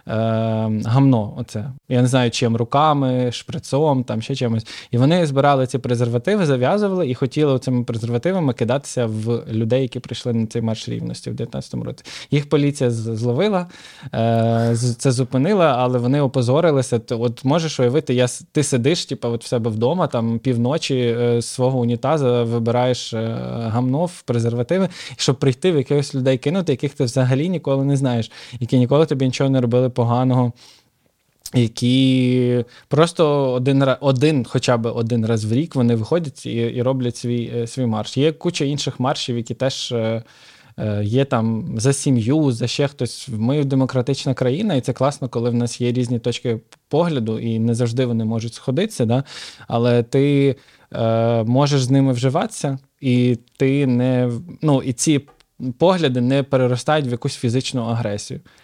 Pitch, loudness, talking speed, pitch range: 125 Hz, -19 LUFS, 155 wpm, 120-140 Hz